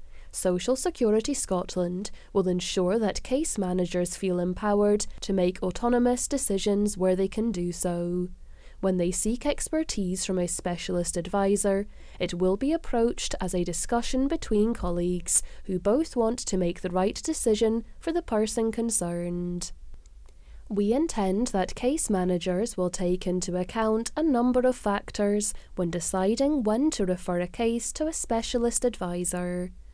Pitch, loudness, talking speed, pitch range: 195 Hz, -27 LUFS, 145 wpm, 180-230 Hz